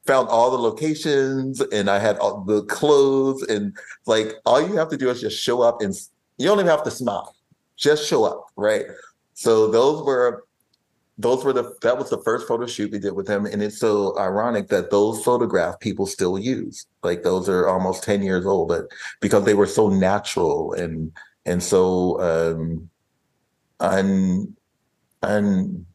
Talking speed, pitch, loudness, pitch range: 180 wpm, 110 Hz, -21 LUFS, 100-140 Hz